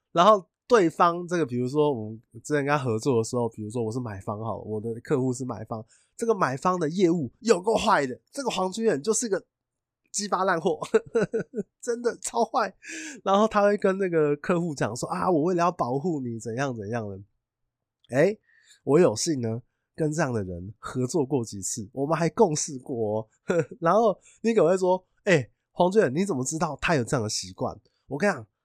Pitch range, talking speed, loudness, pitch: 120-195 Hz, 290 characters per minute, -26 LUFS, 155 Hz